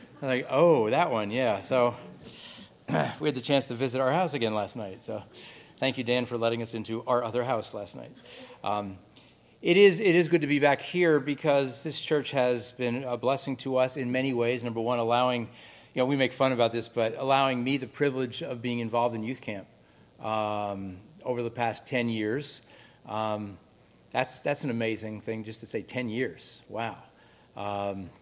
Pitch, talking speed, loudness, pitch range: 125 Hz, 200 wpm, -28 LUFS, 115-135 Hz